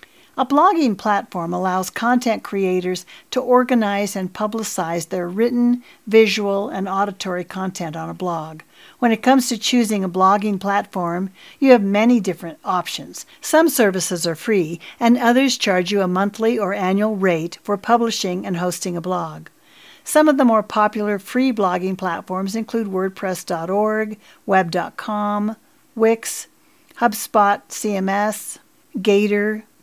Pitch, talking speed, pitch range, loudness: 205 Hz, 135 wpm, 185-235 Hz, -19 LUFS